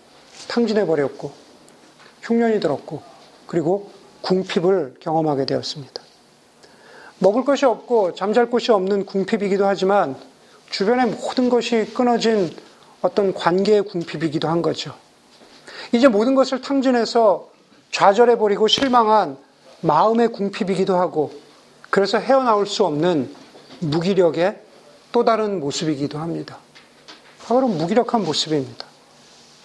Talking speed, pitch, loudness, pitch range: 275 characters per minute, 200 Hz, -19 LUFS, 165-230 Hz